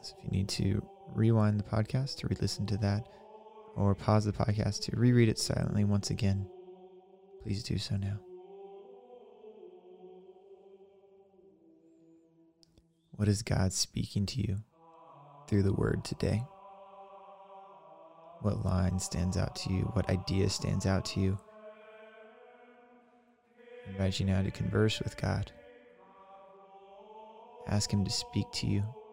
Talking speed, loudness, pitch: 130 wpm, -32 LUFS, 145 Hz